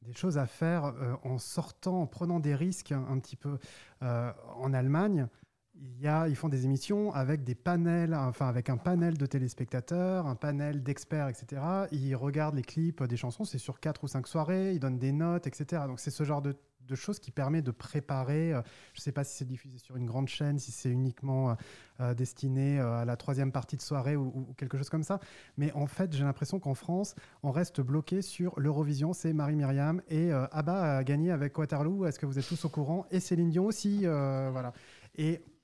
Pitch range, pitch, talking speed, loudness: 130-165 Hz, 145 Hz, 220 wpm, -33 LUFS